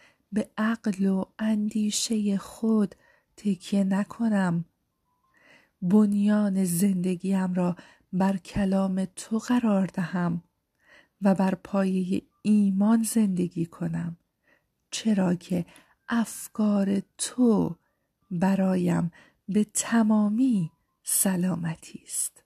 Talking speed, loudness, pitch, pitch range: 80 wpm, -26 LUFS, 195 Hz, 185-215 Hz